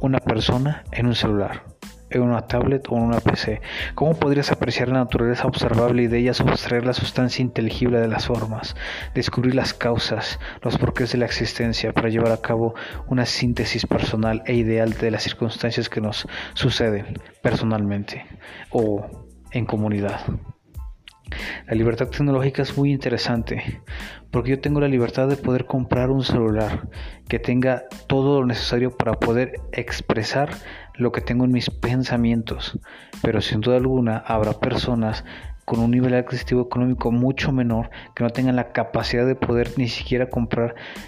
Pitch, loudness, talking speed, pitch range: 120 Hz, -22 LUFS, 160 wpm, 110-125 Hz